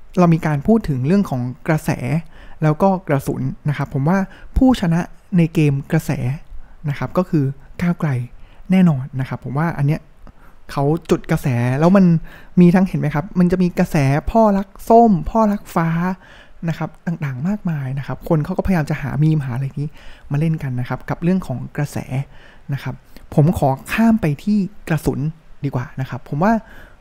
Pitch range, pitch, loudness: 140-180 Hz, 155 Hz, -19 LUFS